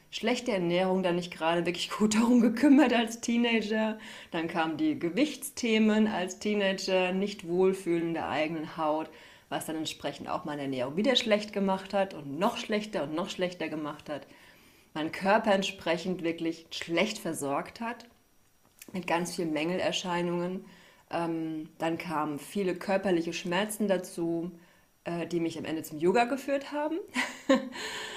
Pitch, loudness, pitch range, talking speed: 185 Hz, -30 LUFS, 165-215 Hz, 140 wpm